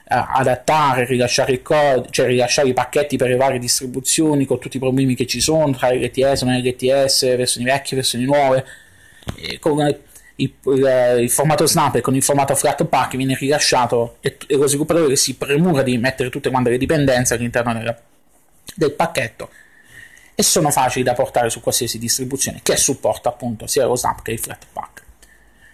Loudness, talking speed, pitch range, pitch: -17 LUFS, 165 wpm, 125-140 Hz, 130 Hz